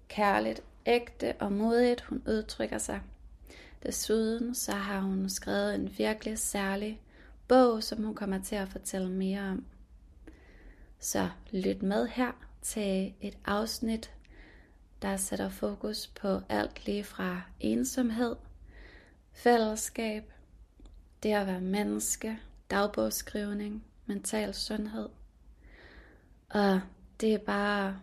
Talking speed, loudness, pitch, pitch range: 110 wpm, -32 LUFS, 205 Hz, 185-220 Hz